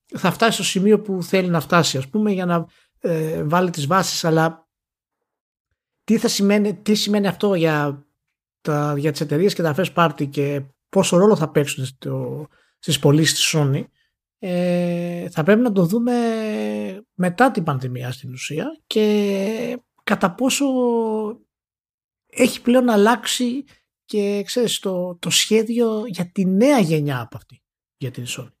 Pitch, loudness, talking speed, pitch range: 180 Hz, -20 LUFS, 150 wpm, 155-215 Hz